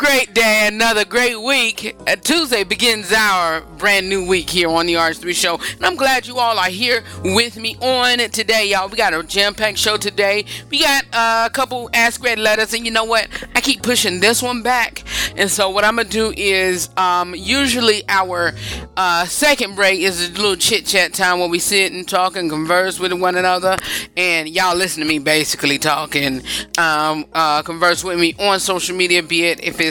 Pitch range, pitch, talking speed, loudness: 175-230 Hz, 195 Hz, 205 wpm, -15 LUFS